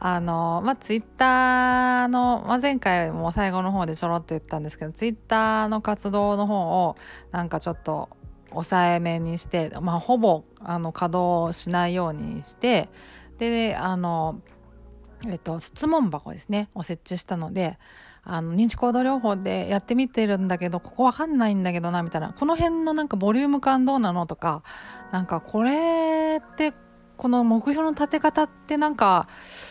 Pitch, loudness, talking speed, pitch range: 200 Hz, -24 LUFS, 335 characters per minute, 175-250 Hz